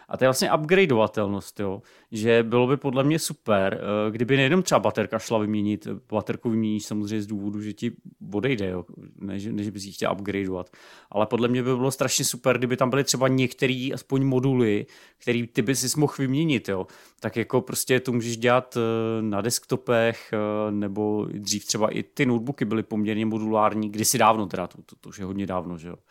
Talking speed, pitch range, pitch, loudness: 185 wpm, 105-130 Hz, 110 Hz, -24 LUFS